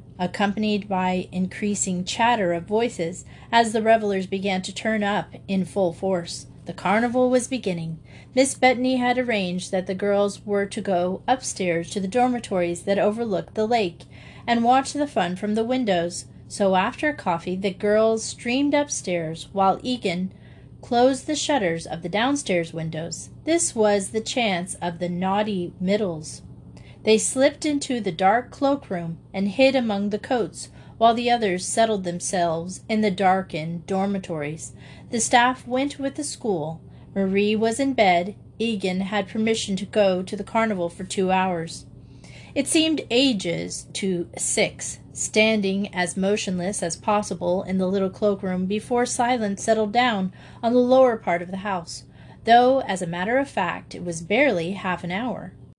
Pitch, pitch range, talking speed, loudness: 200 Hz, 180-235 Hz, 160 wpm, -23 LUFS